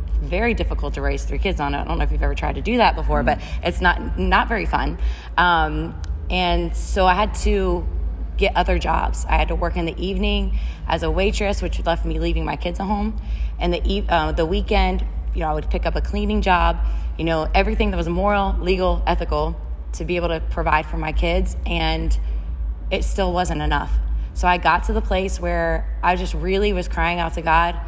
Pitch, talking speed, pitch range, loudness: 170 Hz, 220 wpm, 145-185 Hz, -21 LUFS